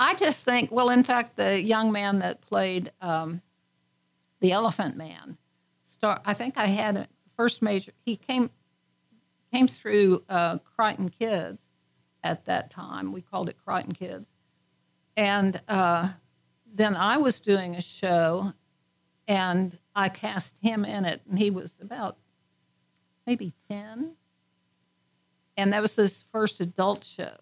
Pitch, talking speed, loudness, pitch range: 195 Hz, 140 wpm, -27 LUFS, 165-215 Hz